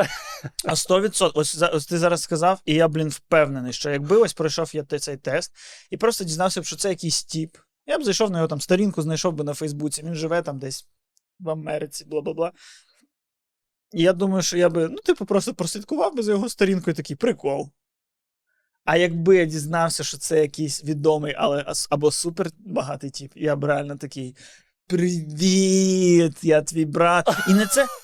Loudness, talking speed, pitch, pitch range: -22 LUFS, 180 wpm, 165 Hz, 150-185 Hz